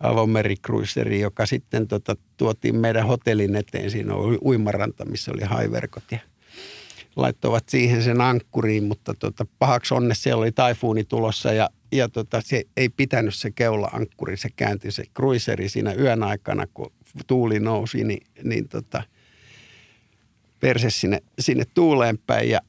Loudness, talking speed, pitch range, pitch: -23 LUFS, 145 wpm, 105-125 Hz, 115 Hz